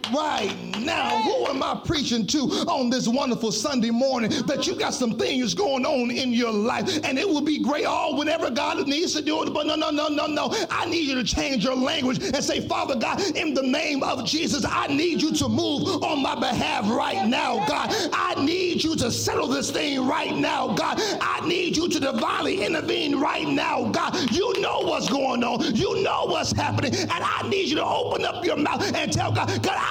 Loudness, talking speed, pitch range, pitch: -24 LUFS, 220 wpm, 265-325 Hz, 300 Hz